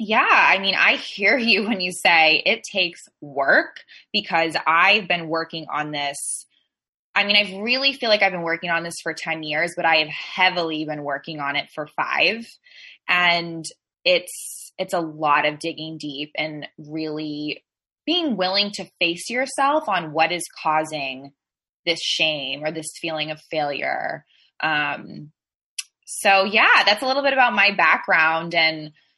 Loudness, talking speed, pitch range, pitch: -20 LUFS, 160 wpm, 155-205 Hz, 165 Hz